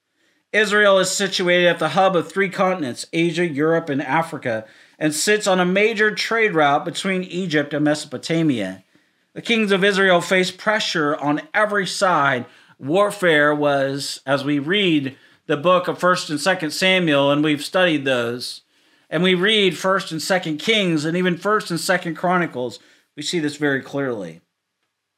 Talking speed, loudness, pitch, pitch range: 160 wpm, -19 LUFS, 170 Hz, 150-190 Hz